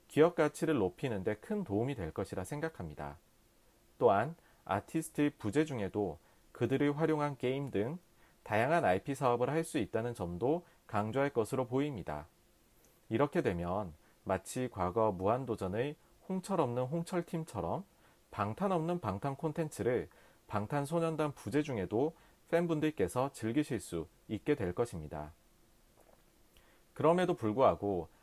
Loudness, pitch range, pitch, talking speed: -35 LUFS, 100-160 Hz, 135 Hz, 285 characters per minute